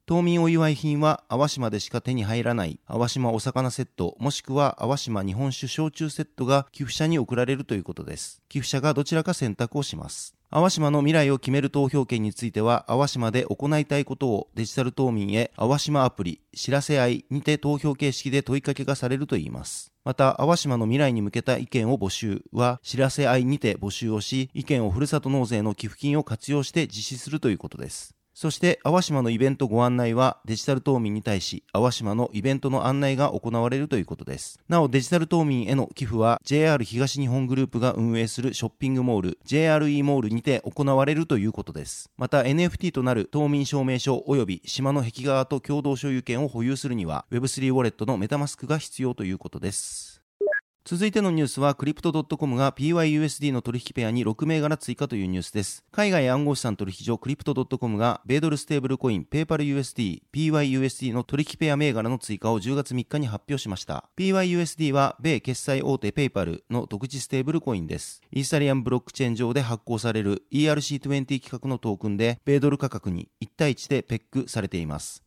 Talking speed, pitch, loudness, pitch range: 425 characters per minute, 135 Hz, -25 LUFS, 115-145 Hz